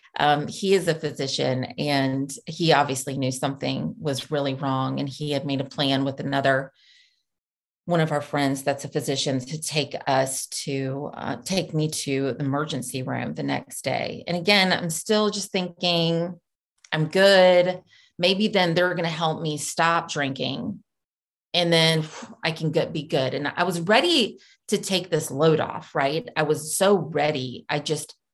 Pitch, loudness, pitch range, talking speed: 155 Hz, -24 LUFS, 140-175 Hz, 175 wpm